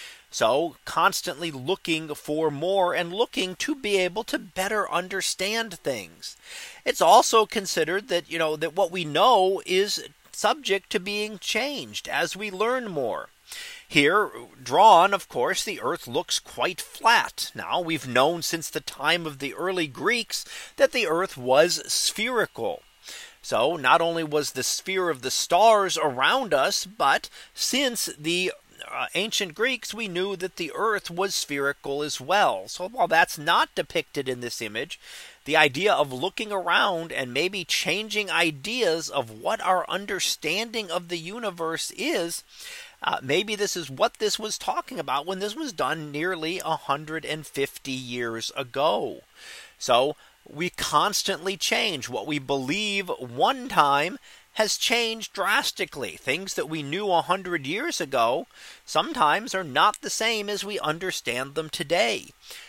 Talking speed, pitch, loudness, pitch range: 150 wpm, 180 Hz, -25 LUFS, 155-210 Hz